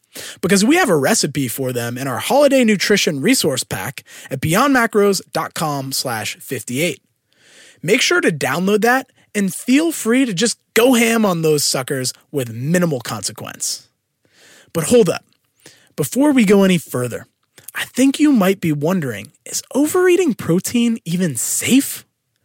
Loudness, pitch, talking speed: -17 LUFS, 200 Hz, 145 wpm